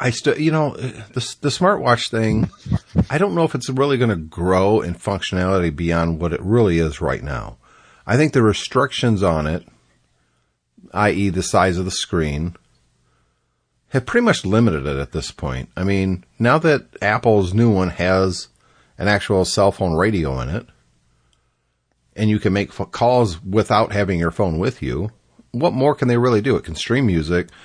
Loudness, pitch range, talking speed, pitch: -19 LUFS, 80-120 Hz, 180 wpm, 100 Hz